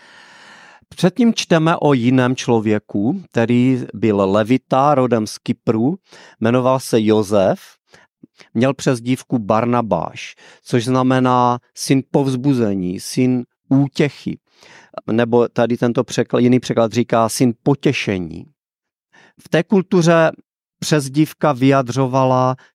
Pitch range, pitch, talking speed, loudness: 120-145 Hz, 130 Hz, 100 wpm, -17 LUFS